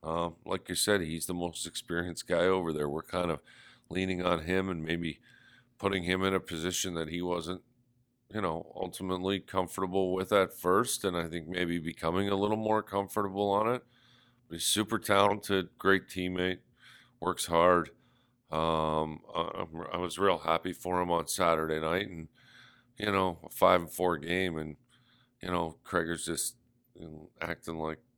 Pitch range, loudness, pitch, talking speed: 85-100 Hz, -31 LUFS, 90 Hz, 175 wpm